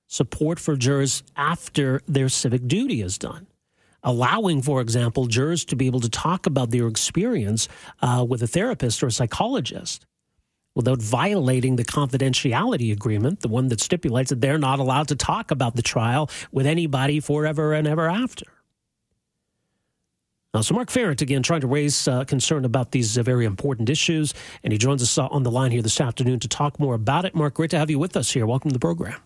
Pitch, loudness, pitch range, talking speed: 135 Hz, -22 LUFS, 125-150 Hz, 195 wpm